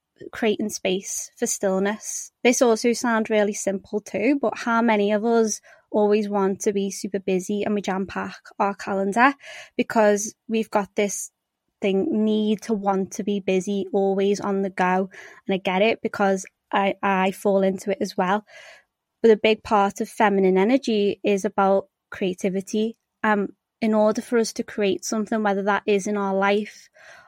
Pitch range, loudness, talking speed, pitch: 195-220 Hz, -23 LUFS, 170 wpm, 210 Hz